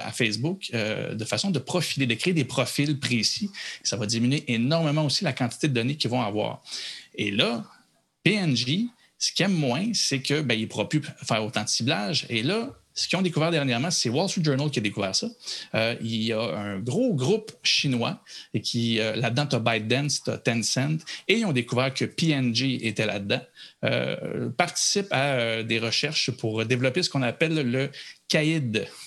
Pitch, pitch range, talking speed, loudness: 130 Hz, 115-155 Hz, 195 wpm, -25 LUFS